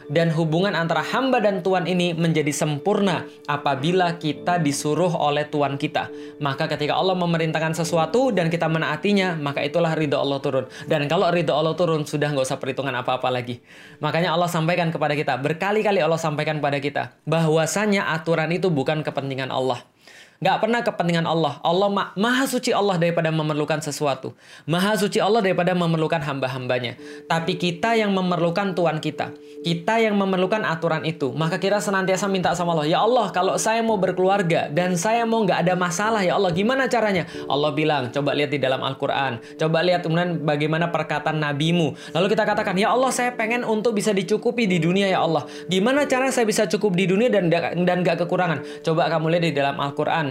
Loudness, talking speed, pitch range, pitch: -22 LUFS, 180 wpm, 150-195 Hz, 165 Hz